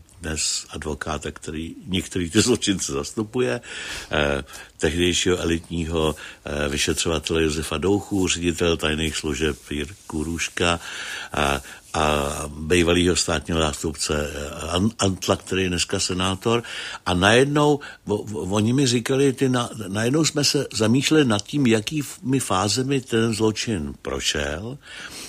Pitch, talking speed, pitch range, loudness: 90 Hz, 110 wpm, 80-110 Hz, -22 LUFS